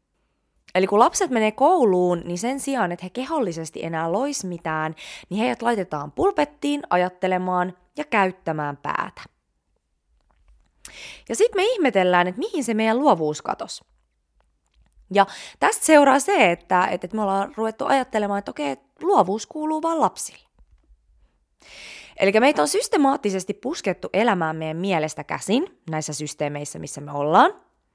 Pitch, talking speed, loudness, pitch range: 195 Hz, 135 wpm, -22 LUFS, 165-275 Hz